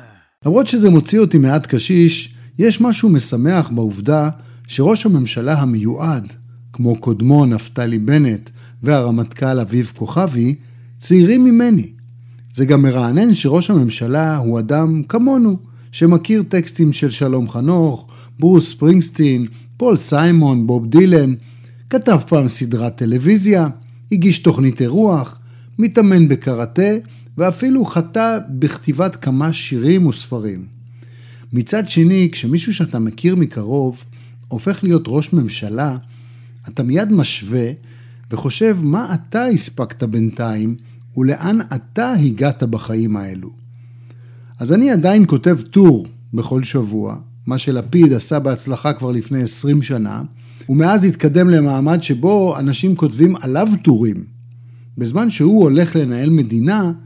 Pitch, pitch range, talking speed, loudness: 140 Hz, 120-170 Hz, 115 wpm, -15 LUFS